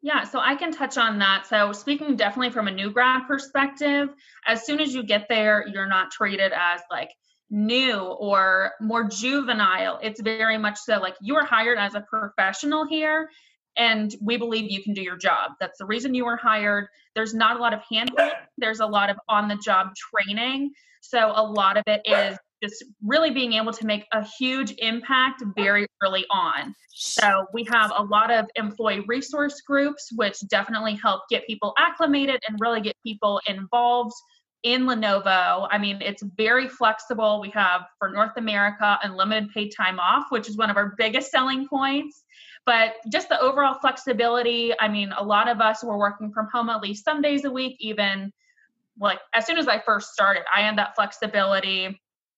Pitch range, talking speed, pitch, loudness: 205-260 Hz, 190 wpm, 220 Hz, -23 LUFS